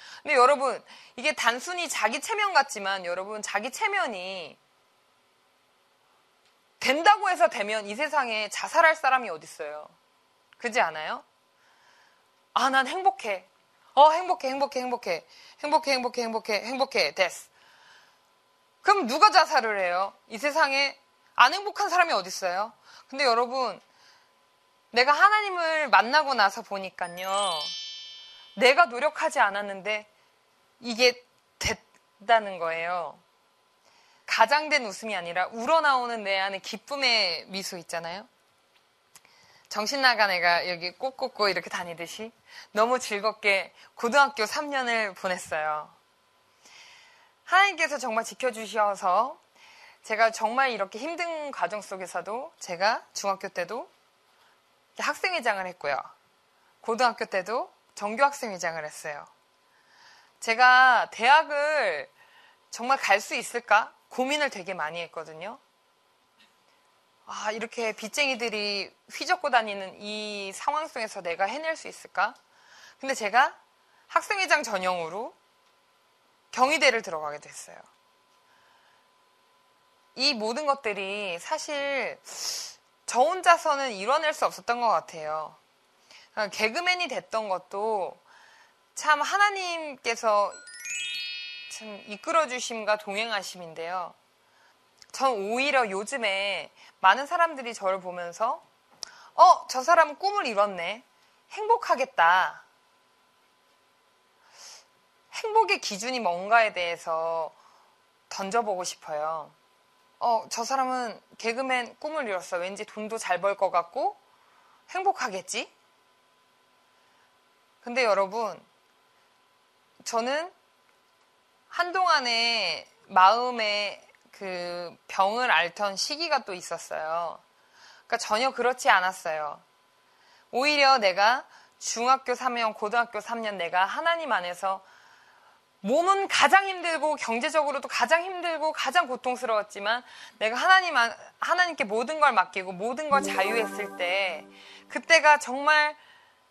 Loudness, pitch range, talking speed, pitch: -26 LUFS, 195-300 Hz, 240 characters per minute, 235 Hz